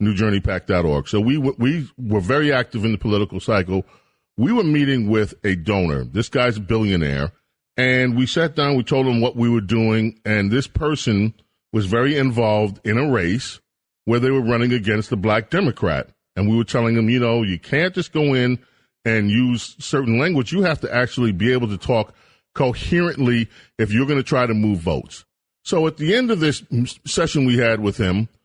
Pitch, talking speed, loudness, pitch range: 115 Hz, 200 wpm, -19 LUFS, 105-130 Hz